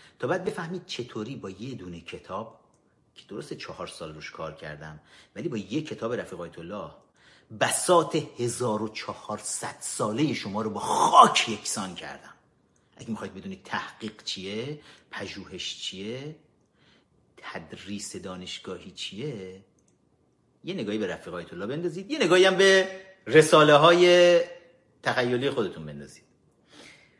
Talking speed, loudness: 125 wpm, -25 LUFS